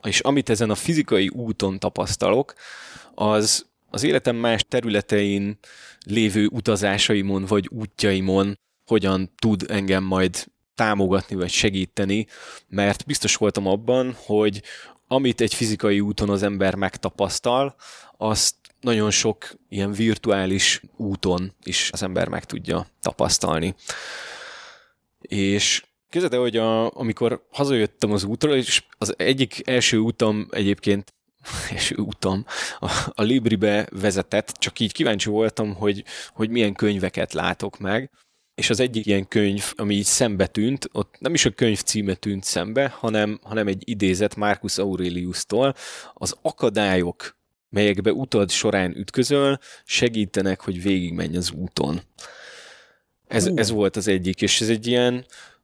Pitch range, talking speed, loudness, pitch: 100-115 Hz, 130 wpm, -22 LUFS, 105 Hz